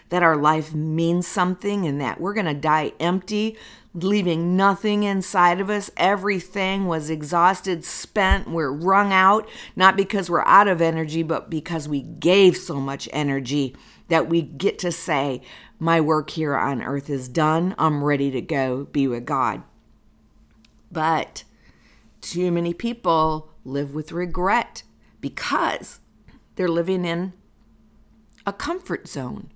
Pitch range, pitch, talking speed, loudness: 150-190 Hz, 170 Hz, 140 wpm, -22 LUFS